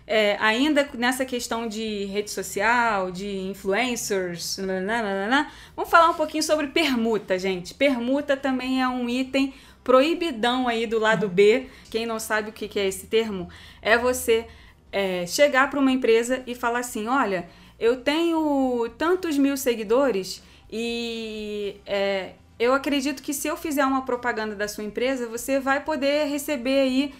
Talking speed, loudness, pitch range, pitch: 150 wpm, -24 LUFS, 215-275 Hz, 240 Hz